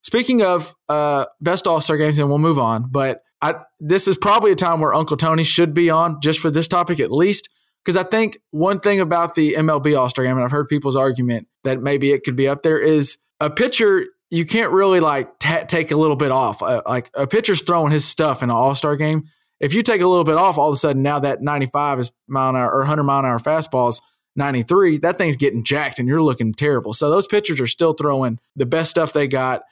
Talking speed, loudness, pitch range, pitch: 245 wpm, -18 LUFS, 140-170 Hz, 150 Hz